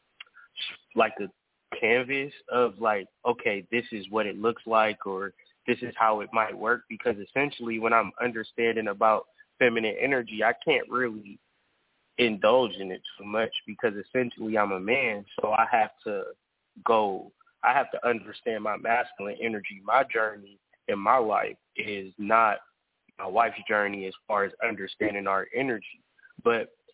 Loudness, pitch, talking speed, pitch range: -27 LUFS, 110 Hz, 155 wpm, 100-120 Hz